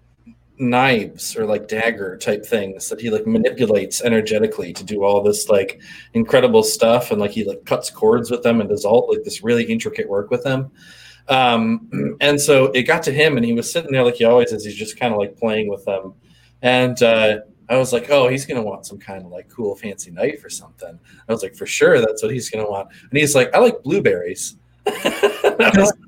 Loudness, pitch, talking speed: -18 LUFS, 125 Hz, 215 wpm